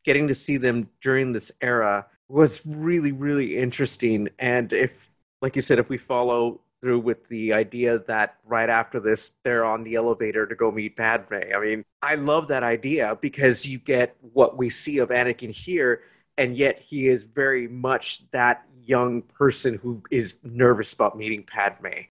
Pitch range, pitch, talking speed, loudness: 115-135 Hz, 120 Hz, 175 wpm, -23 LUFS